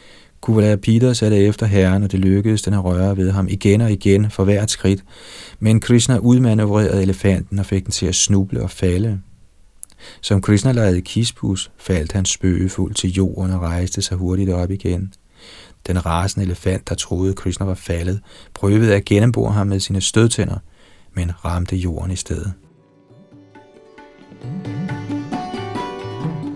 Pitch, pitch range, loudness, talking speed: 95 Hz, 95-105 Hz, -18 LUFS, 155 wpm